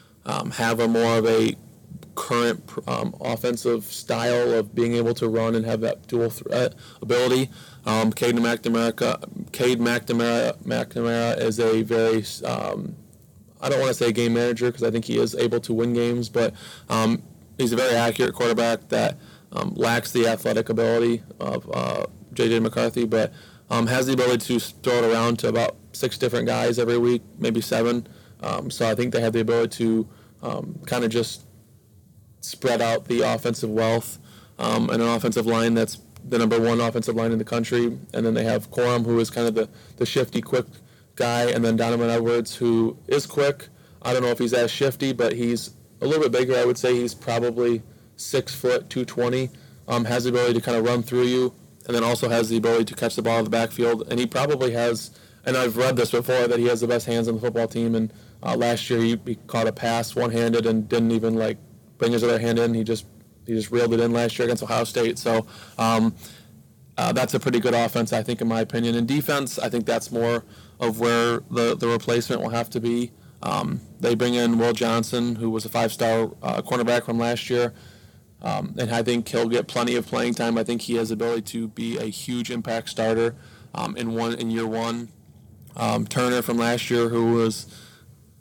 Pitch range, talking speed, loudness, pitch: 115-120 Hz, 210 wpm, -23 LUFS, 115 Hz